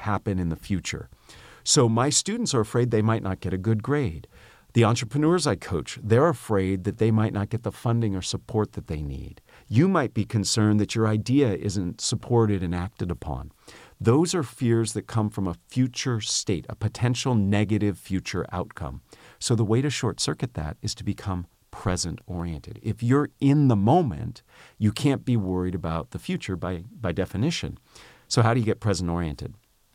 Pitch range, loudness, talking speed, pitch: 95-120 Hz, -25 LUFS, 190 wpm, 110 Hz